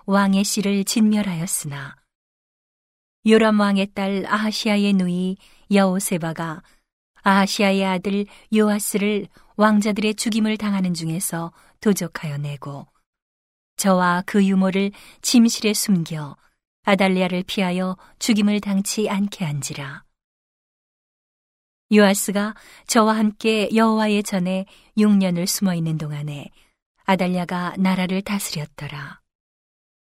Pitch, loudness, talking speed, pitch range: 195 Hz, -20 LUFS, 240 characters per minute, 180-210 Hz